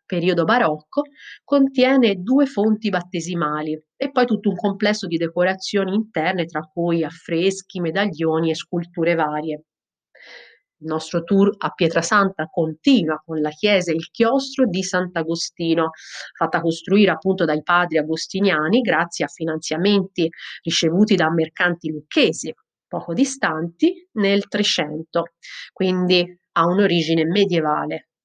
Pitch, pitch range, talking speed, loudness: 175 Hz, 160-200 Hz, 120 wpm, -20 LUFS